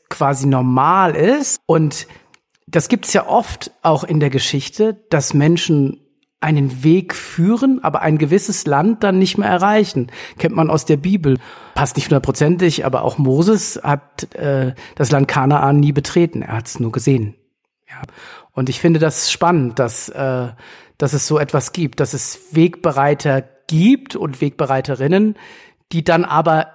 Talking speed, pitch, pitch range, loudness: 160 wpm, 150 Hz, 135-175 Hz, -16 LUFS